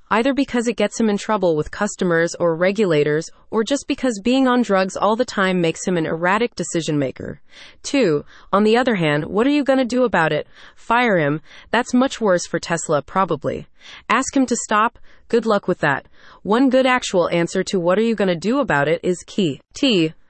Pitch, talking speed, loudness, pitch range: 200 Hz, 210 wpm, -19 LUFS, 170-240 Hz